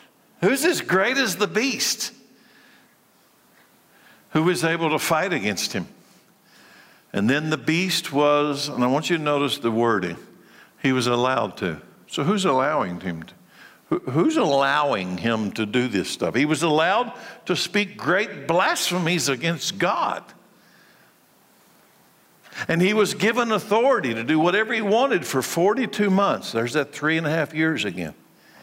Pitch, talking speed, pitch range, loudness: 160 Hz, 155 wpm, 140-205 Hz, -22 LUFS